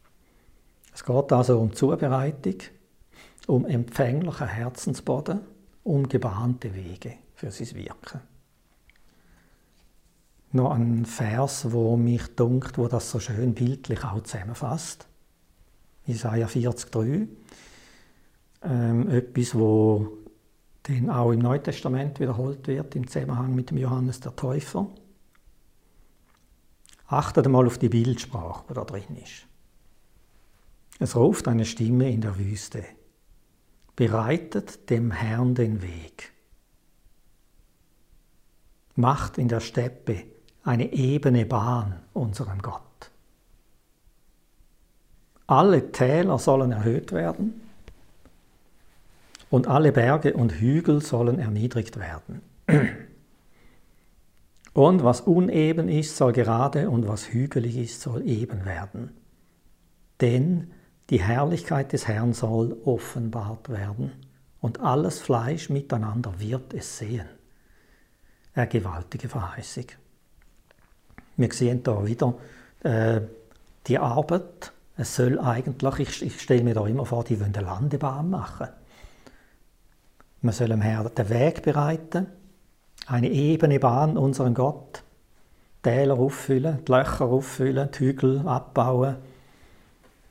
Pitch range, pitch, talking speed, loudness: 115-135 Hz, 125 Hz, 105 wpm, -25 LUFS